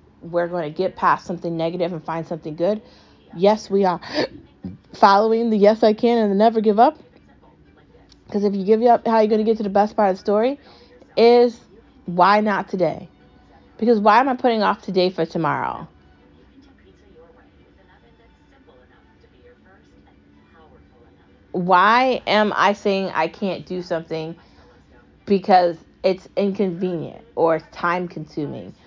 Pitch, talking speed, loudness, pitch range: 190 Hz, 145 wpm, -19 LUFS, 165-215 Hz